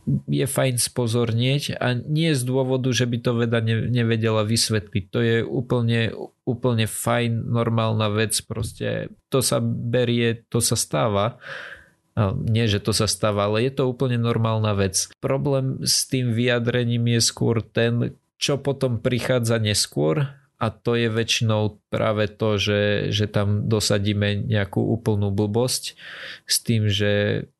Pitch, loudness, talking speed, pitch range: 115 Hz, -22 LUFS, 145 wpm, 105-125 Hz